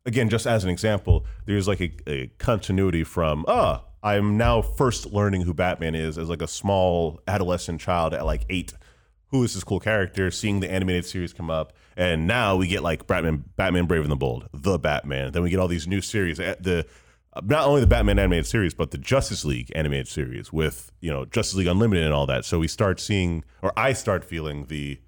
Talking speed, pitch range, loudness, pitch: 220 wpm, 80-100 Hz, -24 LUFS, 90 Hz